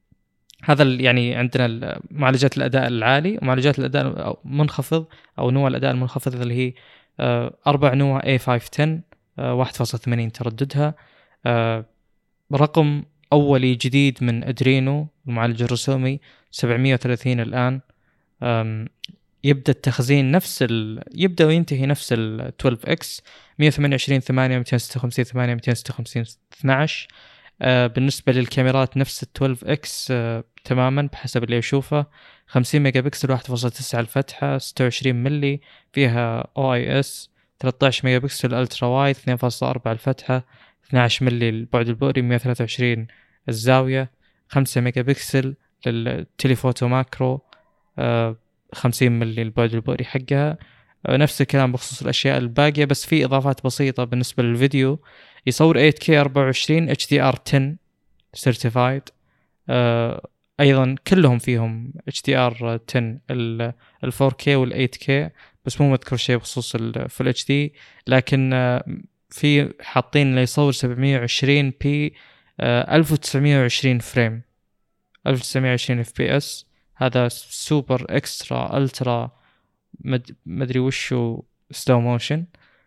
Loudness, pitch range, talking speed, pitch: -20 LUFS, 120-140 Hz, 100 wpm, 130 Hz